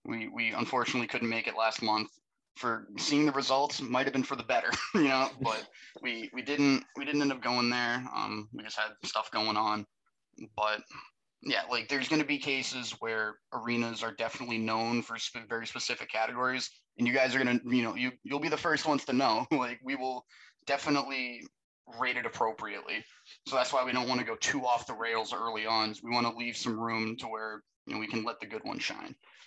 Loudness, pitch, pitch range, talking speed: -32 LUFS, 120 Hz, 115-130 Hz, 220 wpm